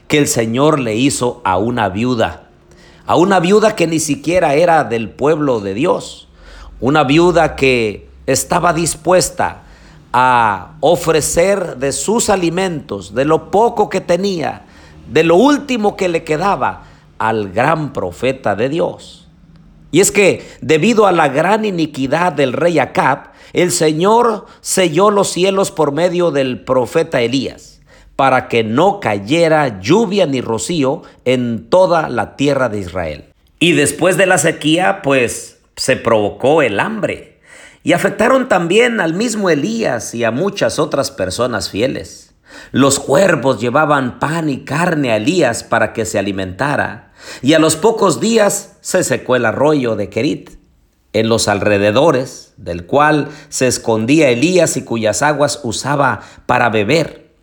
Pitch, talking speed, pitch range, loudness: 150 Hz, 145 wpm, 120-180 Hz, -14 LUFS